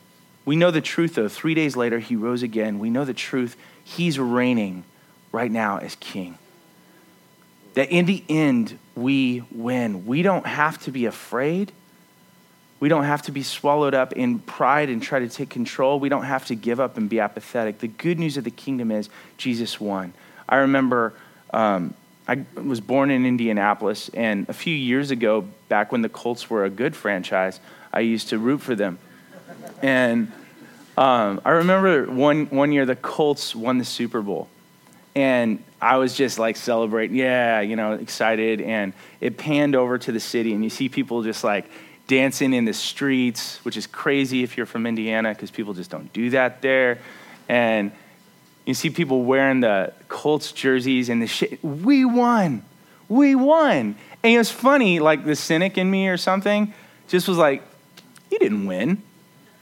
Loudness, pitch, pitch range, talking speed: -22 LUFS, 130 Hz, 115-160 Hz, 180 wpm